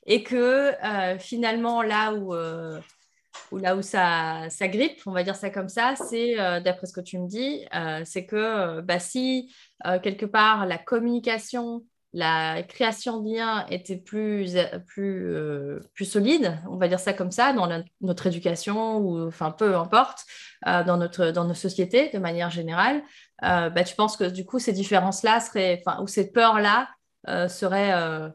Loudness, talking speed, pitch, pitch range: -25 LUFS, 185 wpm, 195 Hz, 175-225 Hz